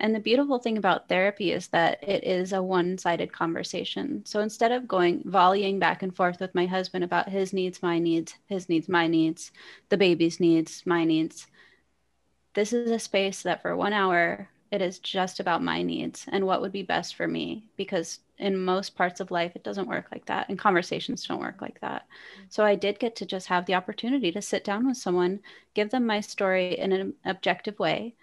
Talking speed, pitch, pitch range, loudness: 210 wpm, 190 Hz, 175-205 Hz, -27 LUFS